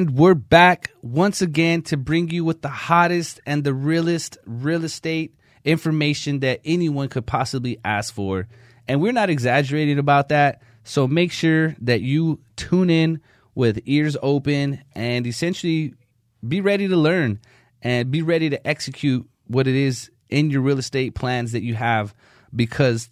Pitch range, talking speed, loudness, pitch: 120-160 Hz, 160 wpm, -20 LUFS, 140 Hz